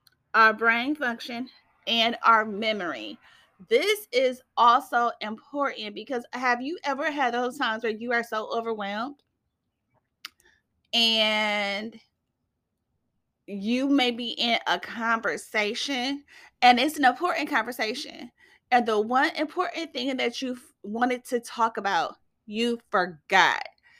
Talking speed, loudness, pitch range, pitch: 120 wpm, -25 LUFS, 225-275 Hz, 245 Hz